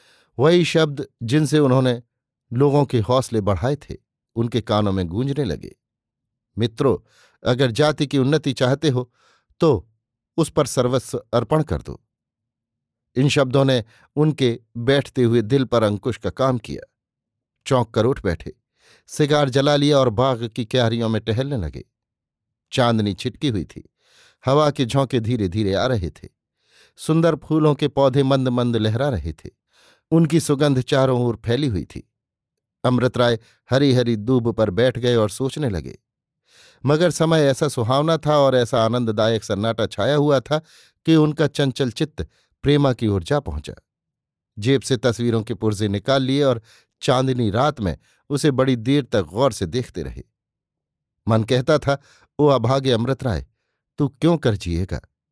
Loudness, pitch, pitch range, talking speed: -20 LUFS, 130 Hz, 115-145 Hz, 155 wpm